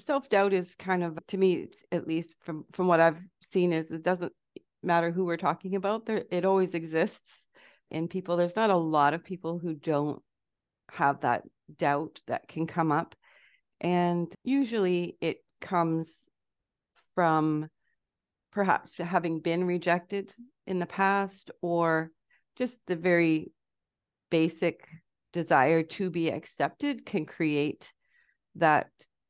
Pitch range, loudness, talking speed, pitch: 165-190 Hz, -29 LUFS, 135 wpm, 175 Hz